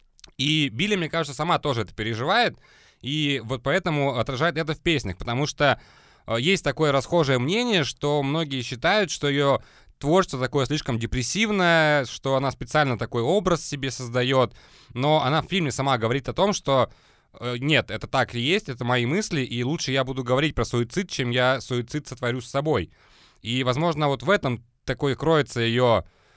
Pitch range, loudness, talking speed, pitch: 125-155 Hz, -24 LUFS, 170 wpm, 135 Hz